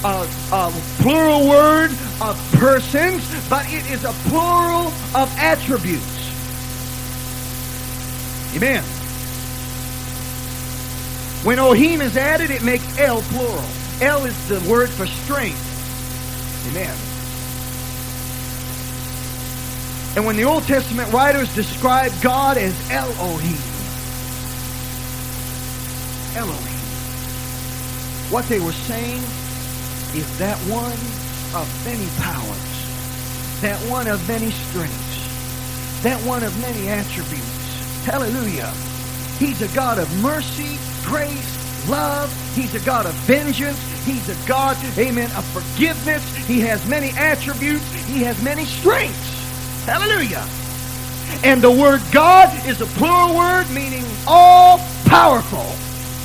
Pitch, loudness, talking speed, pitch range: 125 Hz, -18 LUFS, 105 wpm, 125-175 Hz